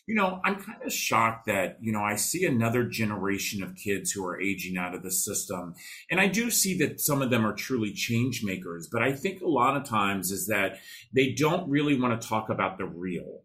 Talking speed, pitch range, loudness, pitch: 230 wpm, 100-140 Hz, -27 LUFS, 115 Hz